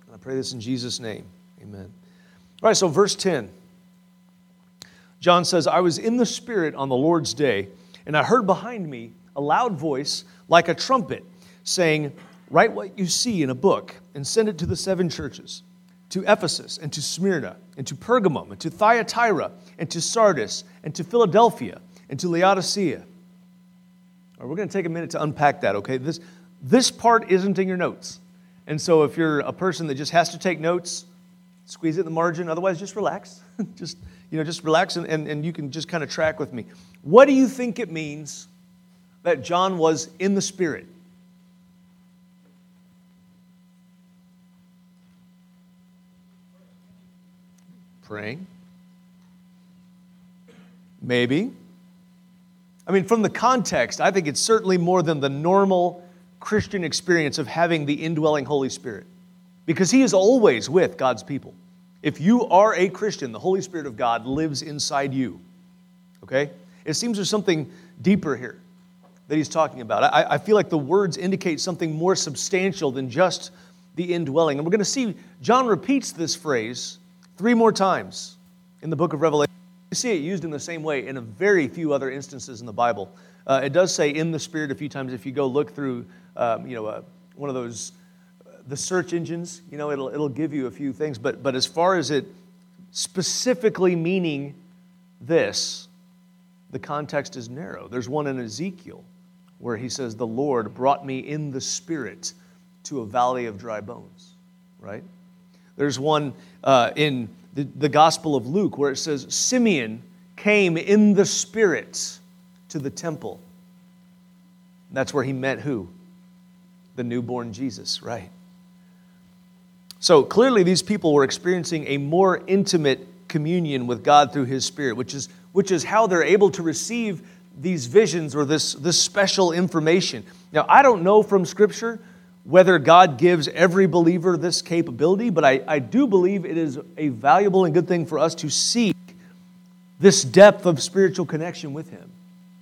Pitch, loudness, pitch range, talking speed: 180 Hz, -21 LUFS, 150-185 Hz, 170 wpm